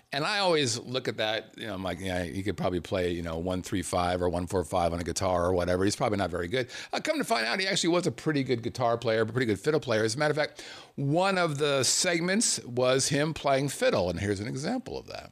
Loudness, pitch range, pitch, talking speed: -28 LUFS, 90-150 Hz, 115 Hz, 285 wpm